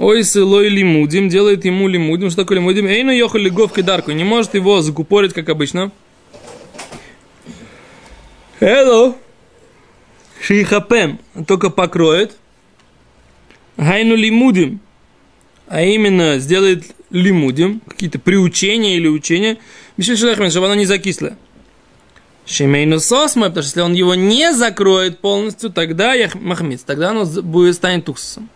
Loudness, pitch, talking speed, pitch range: -13 LUFS, 195 Hz, 110 wpm, 170-210 Hz